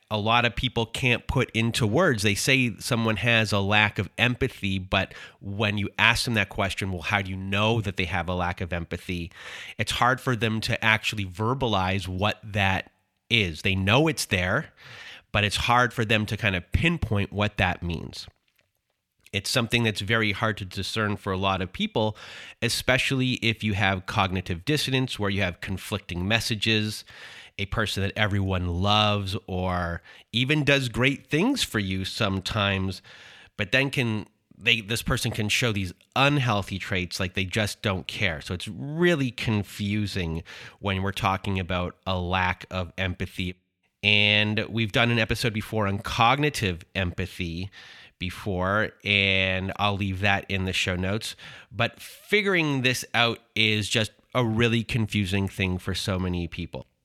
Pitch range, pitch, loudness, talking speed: 95-115 Hz, 105 Hz, -25 LUFS, 165 wpm